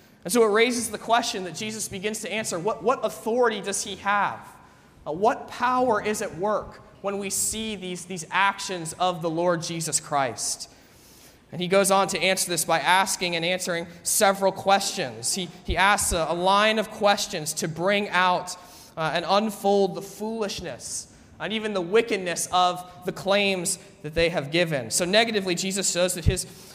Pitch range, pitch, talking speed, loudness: 175-205 Hz, 190 Hz, 180 wpm, -24 LUFS